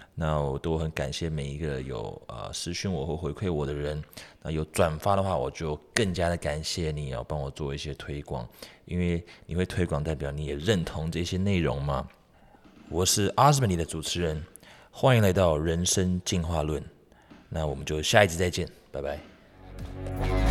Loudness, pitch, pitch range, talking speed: -28 LUFS, 80 Hz, 75-95 Hz, 265 characters per minute